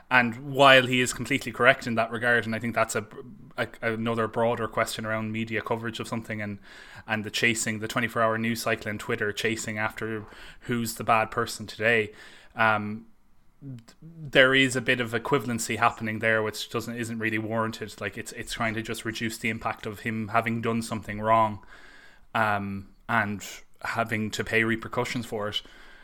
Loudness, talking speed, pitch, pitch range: -26 LUFS, 180 wpm, 115 Hz, 110-120 Hz